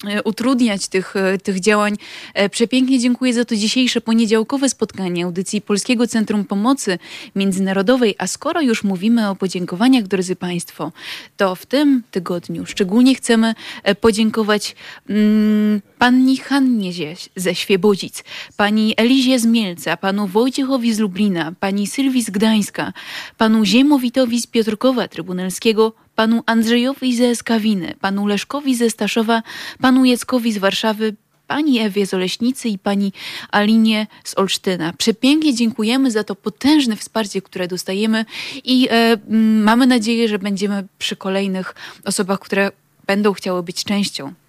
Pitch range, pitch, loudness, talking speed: 195-240 Hz, 220 Hz, -17 LUFS, 125 wpm